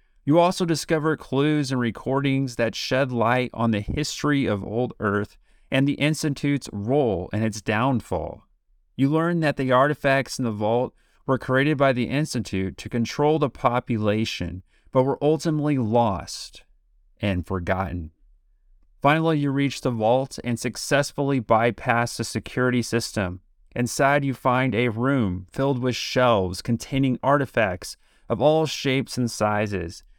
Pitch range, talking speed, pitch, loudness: 110-140 Hz, 140 wpm, 125 Hz, -23 LUFS